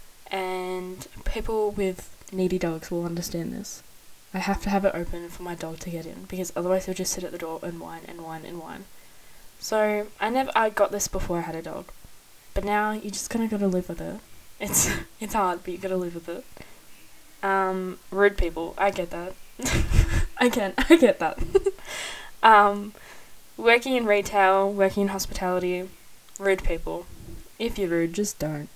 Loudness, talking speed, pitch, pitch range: -25 LUFS, 190 wpm, 190 Hz, 175-205 Hz